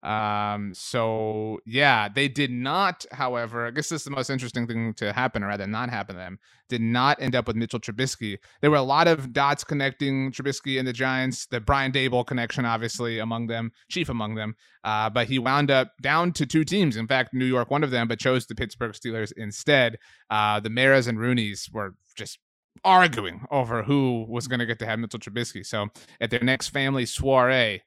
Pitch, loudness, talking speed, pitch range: 120 Hz, -25 LUFS, 210 wpm, 110-135 Hz